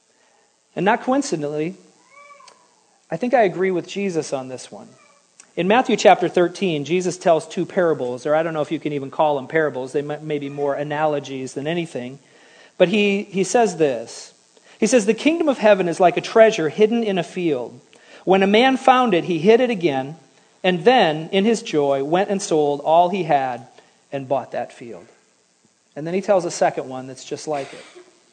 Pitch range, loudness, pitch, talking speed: 150-210 Hz, -19 LUFS, 175 Hz, 195 wpm